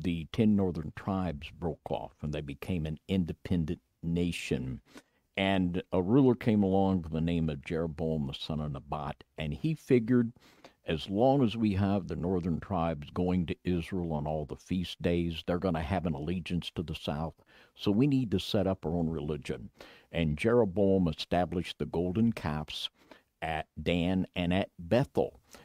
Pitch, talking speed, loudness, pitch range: 90 Hz, 175 wpm, -31 LUFS, 80-95 Hz